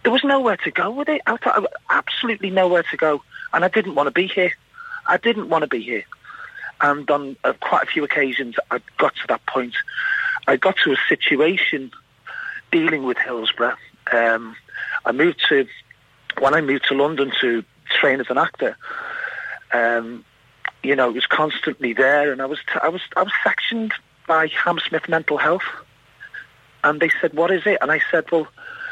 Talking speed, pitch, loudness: 185 wpm, 220 Hz, -19 LUFS